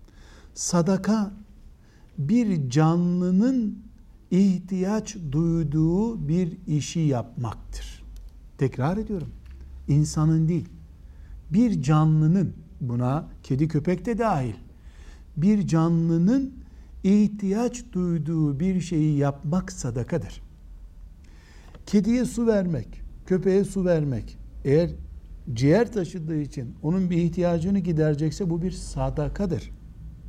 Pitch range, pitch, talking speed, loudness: 125-190 Hz, 160 Hz, 85 wpm, -24 LUFS